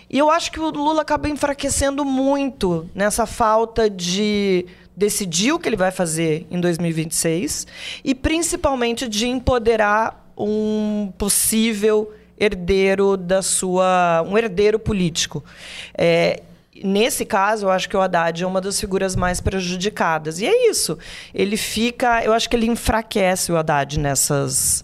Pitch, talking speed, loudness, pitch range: 210 Hz, 145 wpm, -19 LUFS, 180-235 Hz